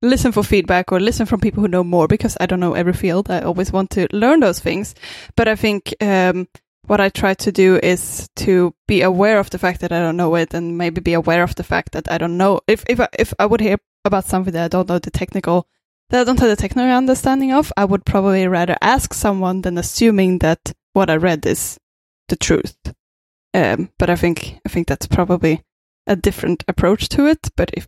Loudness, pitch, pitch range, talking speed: -17 LUFS, 185 Hz, 175-210 Hz, 230 wpm